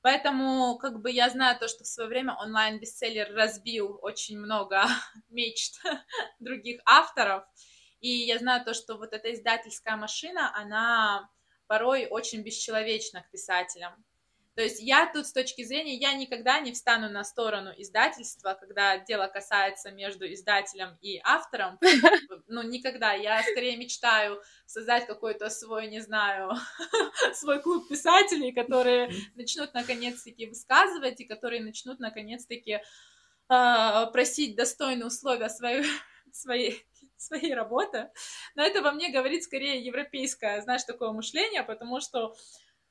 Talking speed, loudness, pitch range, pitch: 130 wpm, -27 LUFS, 220-260 Hz, 235 Hz